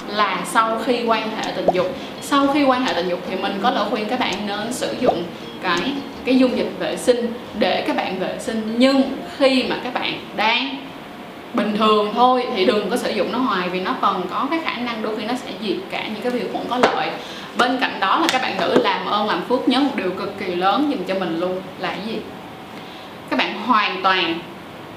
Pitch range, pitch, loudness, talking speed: 195-255 Hz, 235 Hz, -20 LUFS, 235 wpm